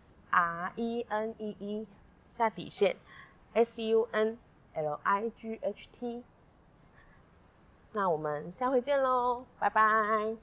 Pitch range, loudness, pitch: 195-230 Hz, -32 LUFS, 220 Hz